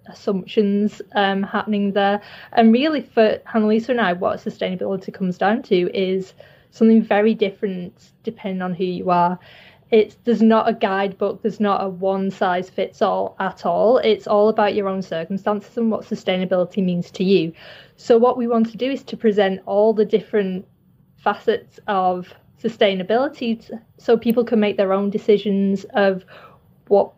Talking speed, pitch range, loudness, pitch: 170 wpm, 190-225 Hz, -20 LUFS, 205 Hz